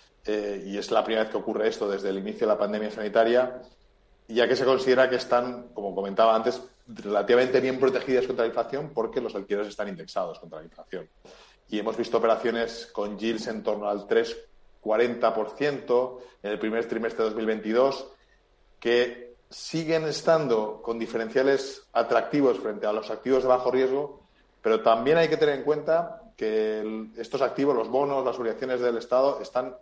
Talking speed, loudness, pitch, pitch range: 175 wpm, -26 LUFS, 120 Hz, 110-135 Hz